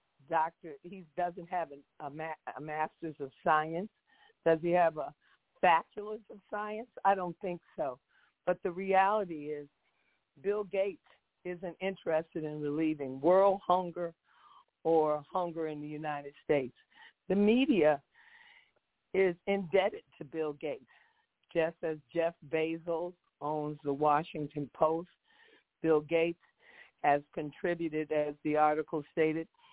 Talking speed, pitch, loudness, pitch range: 125 wpm, 165 Hz, -33 LUFS, 150-190 Hz